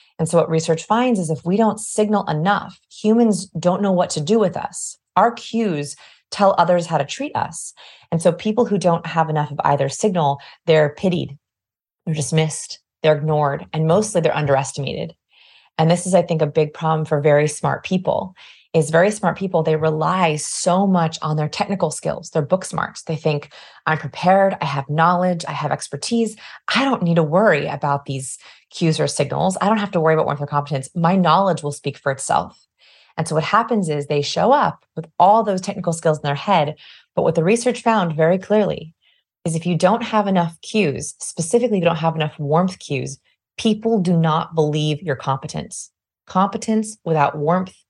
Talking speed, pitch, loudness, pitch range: 195 wpm, 165 Hz, -19 LUFS, 150-195 Hz